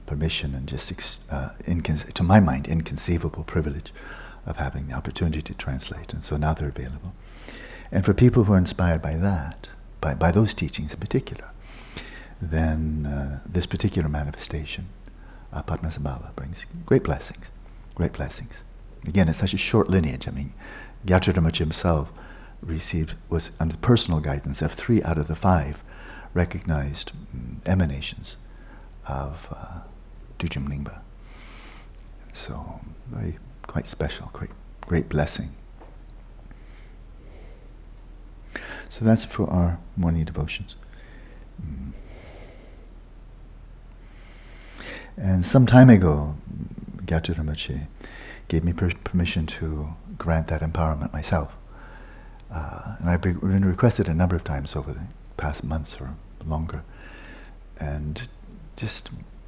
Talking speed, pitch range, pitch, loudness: 120 wpm, 75-95 Hz, 80 Hz, -25 LUFS